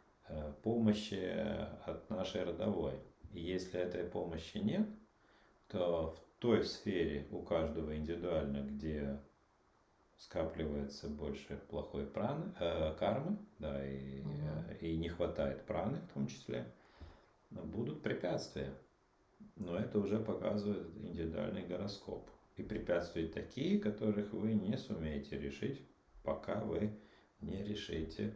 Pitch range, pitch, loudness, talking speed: 75-105 Hz, 85 Hz, -40 LUFS, 110 wpm